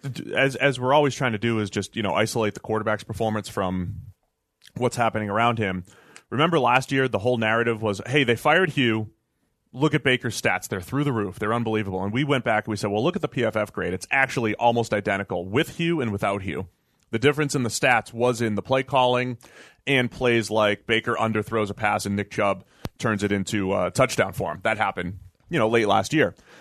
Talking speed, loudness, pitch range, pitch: 220 wpm, -23 LUFS, 105-130 Hz, 115 Hz